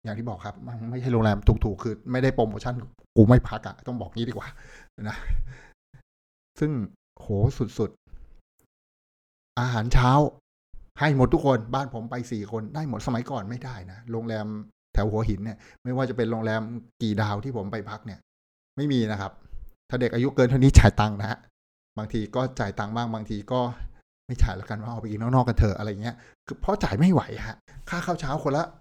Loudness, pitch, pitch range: -26 LUFS, 115 Hz, 105-125 Hz